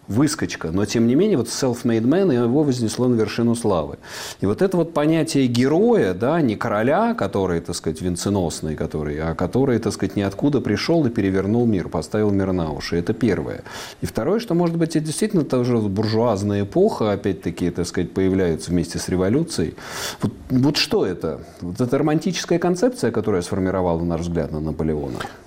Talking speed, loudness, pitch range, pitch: 175 wpm, -21 LUFS, 90-130 Hz, 105 Hz